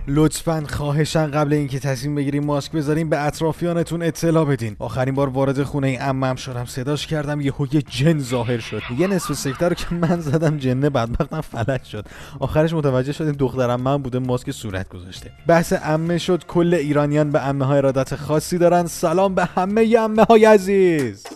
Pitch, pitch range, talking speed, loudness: 145 Hz, 135-165 Hz, 170 wpm, -20 LUFS